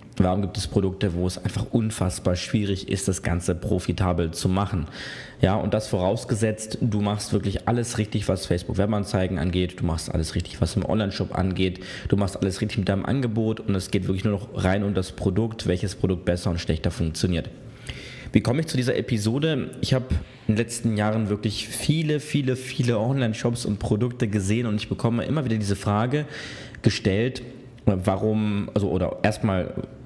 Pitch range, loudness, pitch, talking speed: 95-115 Hz, -25 LUFS, 105 Hz, 180 wpm